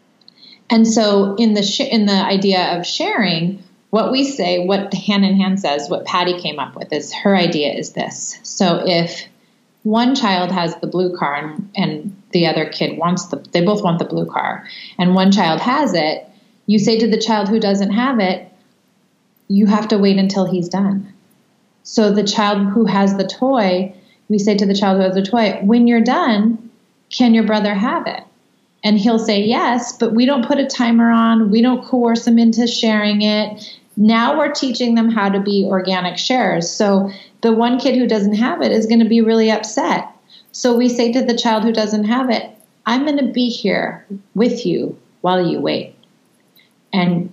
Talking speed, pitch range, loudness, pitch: 195 wpm, 190-230 Hz, -16 LUFS, 210 Hz